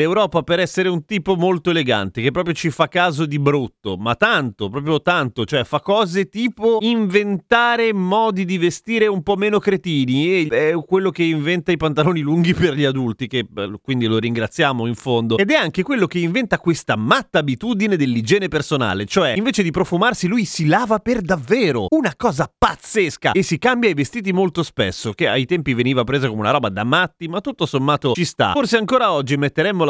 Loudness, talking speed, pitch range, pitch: -18 LUFS, 195 wpm, 140-195 Hz, 170 Hz